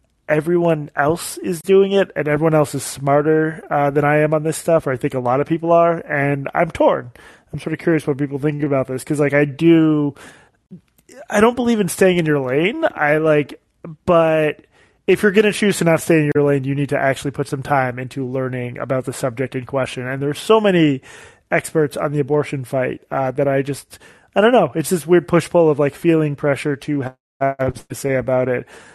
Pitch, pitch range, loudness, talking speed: 150 Hz, 140-165 Hz, -18 LUFS, 220 wpm